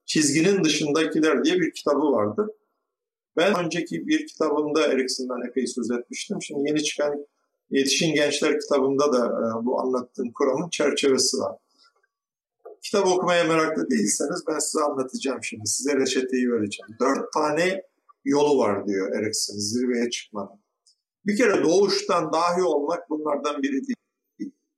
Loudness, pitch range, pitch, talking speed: -23 LUFS, 130-190 Hz, 150 Hz, 130 wpm